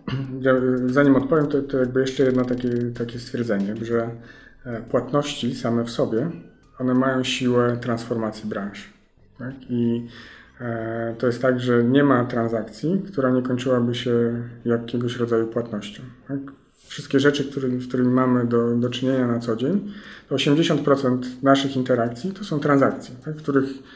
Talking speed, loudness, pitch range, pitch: 150 wpm, -22 LUFS, 120-135 Hz, 125 Hz